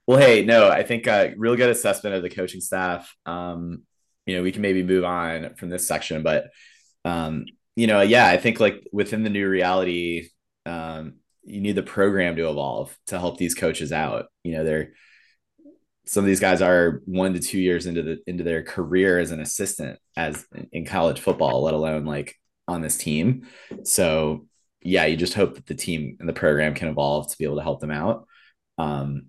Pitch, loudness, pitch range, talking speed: 90 Hz, -22 LUFS, 80-95 Hz, 205 wpm